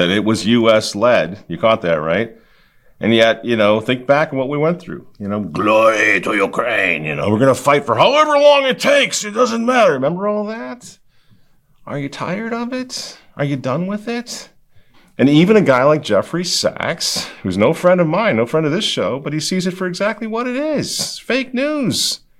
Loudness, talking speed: -16 LUFS, 205 wpm